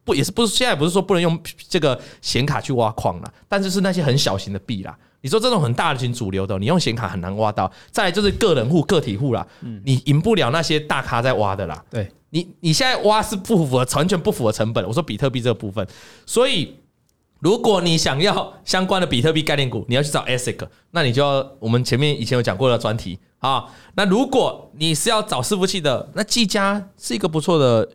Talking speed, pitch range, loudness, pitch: 345 characters per minute, 115-185 Hz, -20 LUFS, 145 Hz